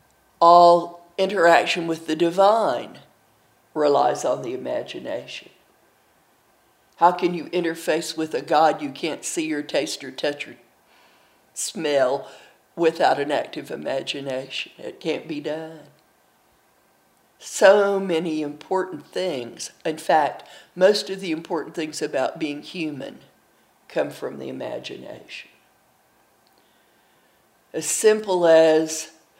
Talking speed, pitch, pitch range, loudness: 110 wpm, 165 Hz, 160-185 Hz, -22 LUFS